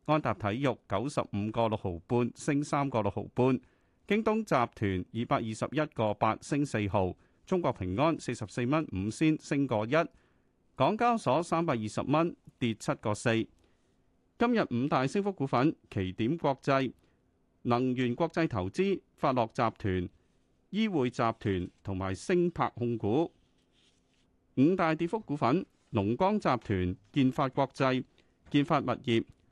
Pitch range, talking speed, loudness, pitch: 110-155 Hz, 215 characters per minute, -31 LUFS, 125 Hz